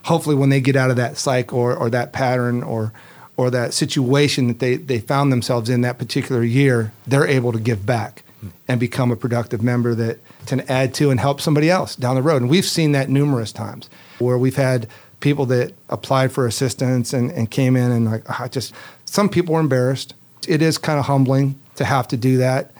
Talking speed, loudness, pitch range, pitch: 220 wpm, -19 LUFS, 120-140 Hz, 130 Hz